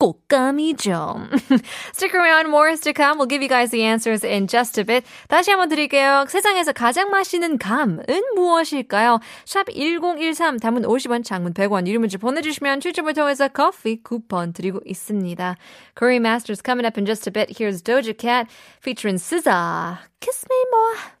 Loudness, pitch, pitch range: -19 LUFS, 255 Hz, 220-320 Hz